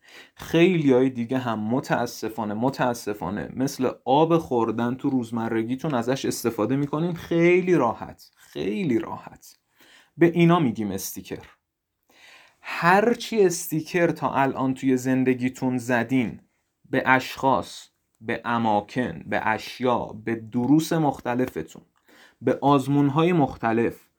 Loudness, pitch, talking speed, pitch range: -23 LUFS, 130 Hz, 100 wpm, 120-160 Hz